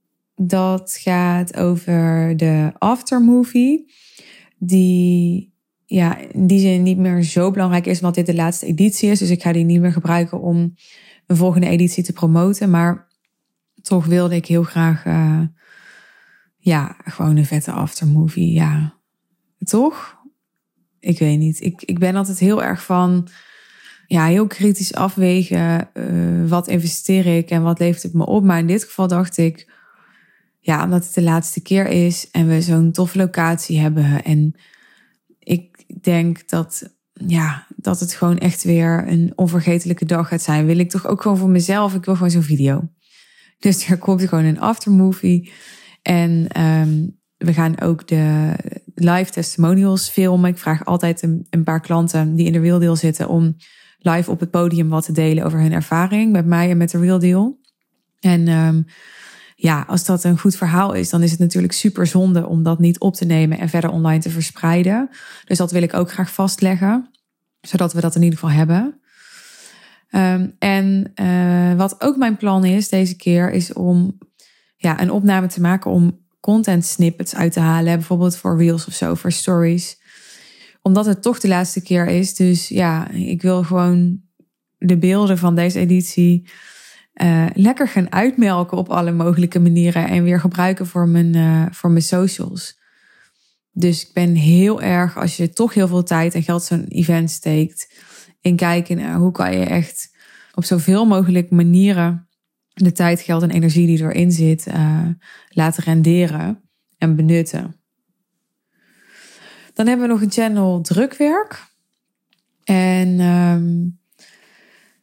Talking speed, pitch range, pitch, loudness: 165 wpm, 170-190 Hz, 175 Hz, -16 LUFS